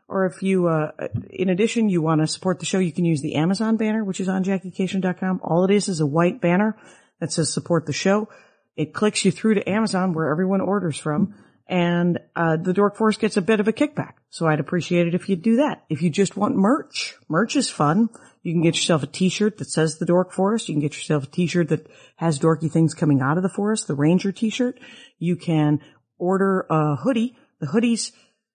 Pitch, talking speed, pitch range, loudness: 185 Hz, 225 wpm, 160-210 Hz, -22 LUFS